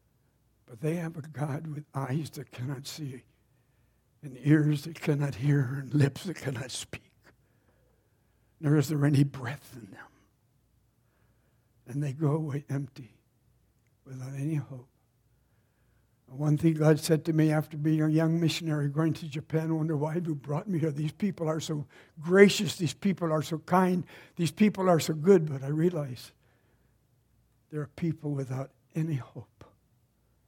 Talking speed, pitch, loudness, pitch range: 160 wpm, 145 Hz, -29 LUFS, 125-155 Hz